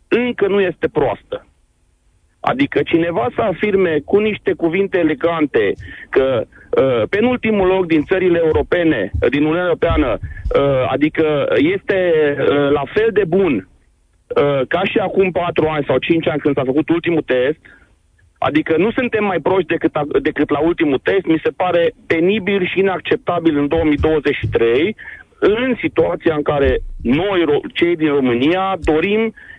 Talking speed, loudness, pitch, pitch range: 150 wpm, -16 LUFS, 175 Hz, 155-210 Hz